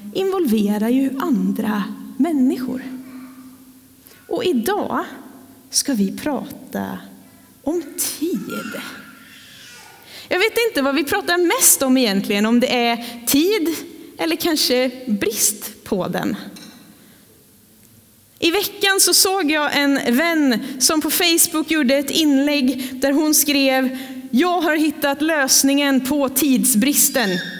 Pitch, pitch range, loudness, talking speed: 275 Hz, 255-315 Hz, -17 LUFS, 110 wpm